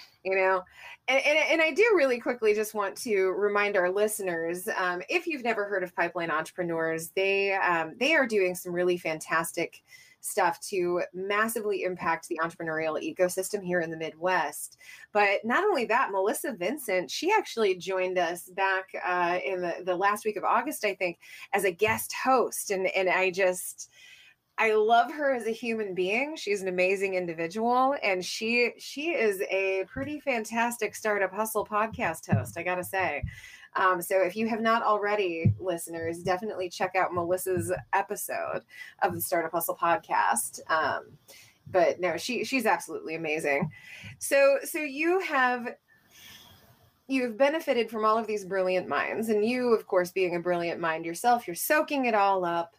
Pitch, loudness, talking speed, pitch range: 195 Hz, -27 LUFS, 170 wpm, 180-230 Hz